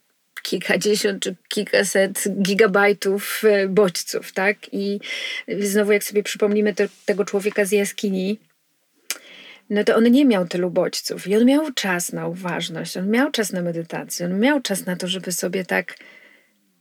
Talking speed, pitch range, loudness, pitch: 150 wpm, 190-210 Hz, -21 LUFS, 205 Hz